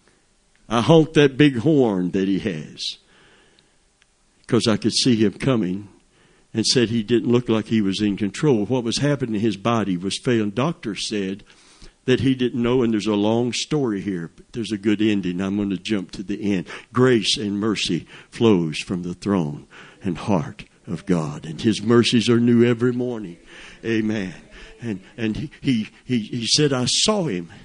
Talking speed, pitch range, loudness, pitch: 180 wpm, 100-125 Hz, -21 LUFS, 110 Hz